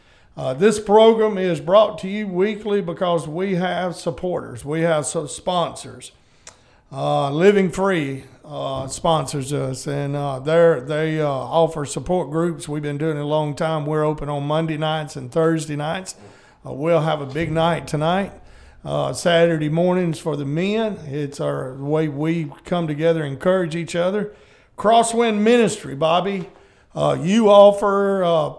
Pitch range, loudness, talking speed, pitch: 150-185 Hz, -20 LUFS, 155 wpm, 165 Hz